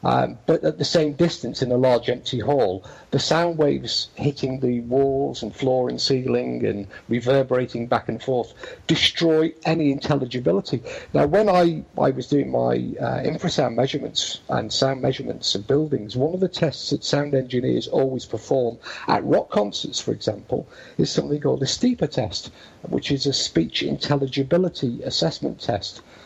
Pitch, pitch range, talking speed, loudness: 135 Hz, 125-150 Hz, 160 wpm, -22 LUFS